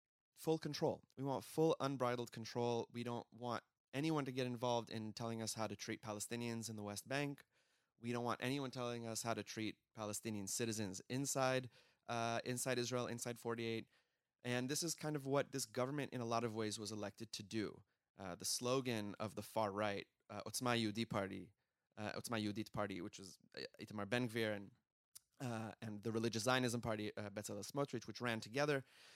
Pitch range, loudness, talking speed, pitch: 110-125 Hz, -43 LUFS, 185 wpm, 115 Hz